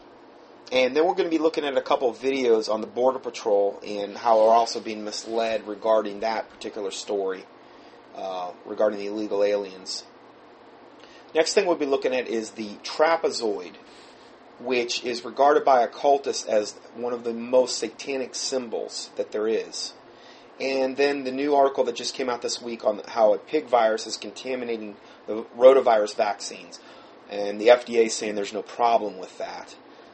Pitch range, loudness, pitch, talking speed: 105-135 Hz, -24 LUFS, 120 Hz, 170 wpm